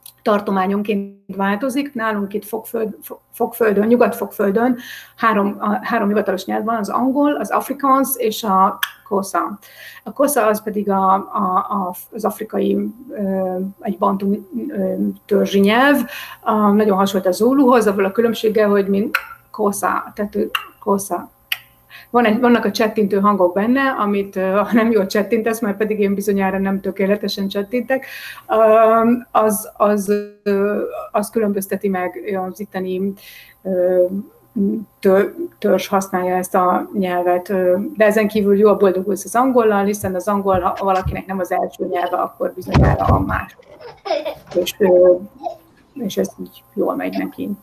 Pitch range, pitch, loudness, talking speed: 195-225 Hz, 205 Hz, -18 LUFS, 130 wpm